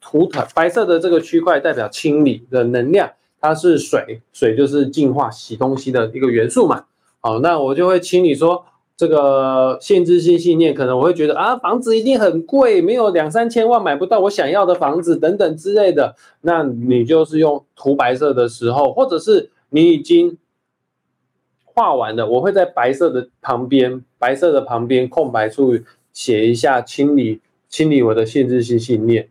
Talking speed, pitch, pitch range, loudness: 270 characters per minute, 150 Hz, 125-180 Hz, -15 LUFS